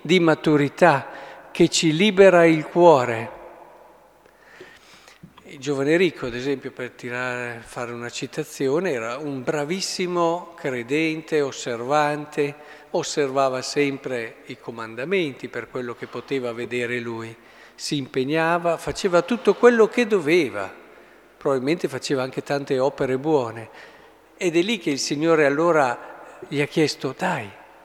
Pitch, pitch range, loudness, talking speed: 150 Hz, 135-170 Hz, -22 LUFS, 120 wpm